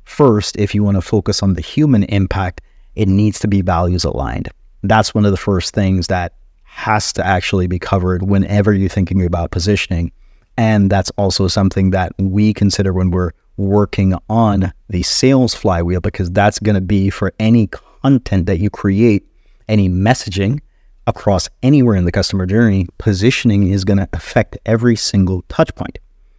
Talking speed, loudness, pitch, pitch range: 170 wpm, -15 LUFS, 100 Hz, 95-110 Hz